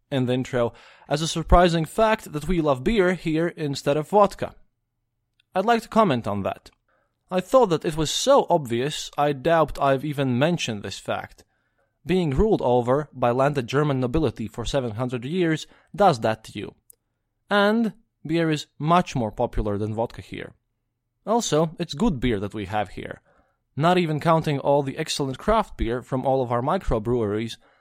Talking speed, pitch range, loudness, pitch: 175 wpm, 120-170 Hz, -23 LUFS, 145 Hz